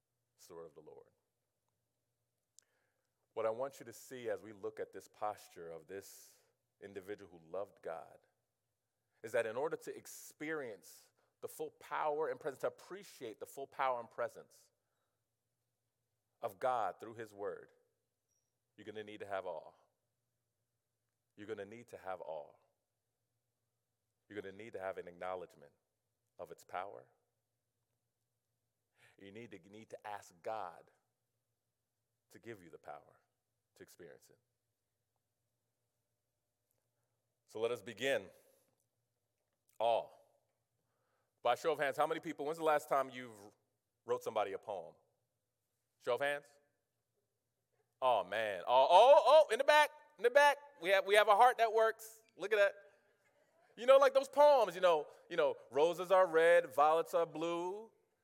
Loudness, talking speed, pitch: -34 LUFS, 155 wpm, 120 Hz